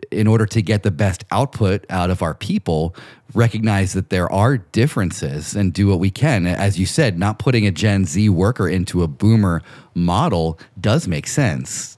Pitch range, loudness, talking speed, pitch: 90-110 Hz, -18 LUFS, 185 wpm, 100 Hz